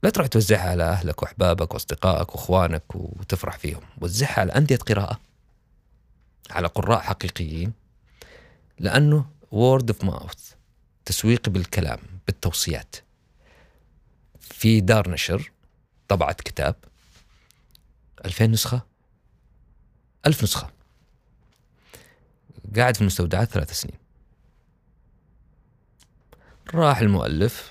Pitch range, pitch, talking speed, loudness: 90-115 Hz, 100 Hz, 85 wpm, -23 LUFS